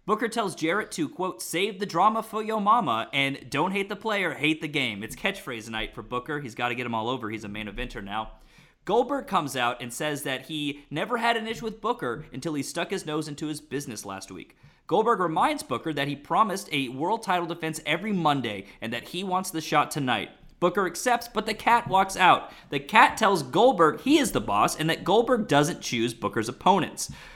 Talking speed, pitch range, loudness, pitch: 220 wpm, 125-195 Hz, -26 LUFS, 155 Hz